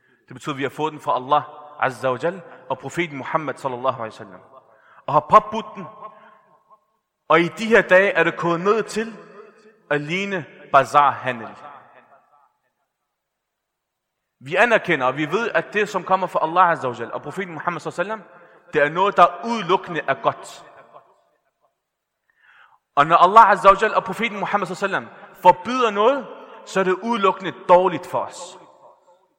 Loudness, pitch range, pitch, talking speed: -19 LUFS, 150-210 Hz, 175 Hz, 165 wpm